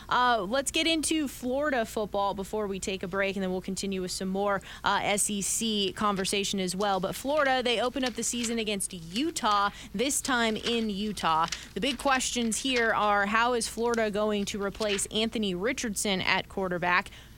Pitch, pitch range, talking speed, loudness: 210 Hz, 195-240 Hz, 175 wpm, -28 LUFS